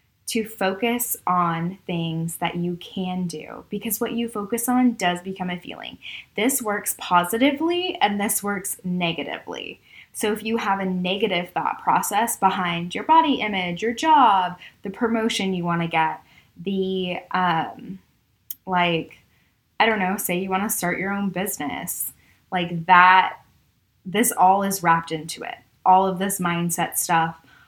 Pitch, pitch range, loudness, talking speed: 190 Hz, 175-220 Hz, -22 LUFS, 150 wpm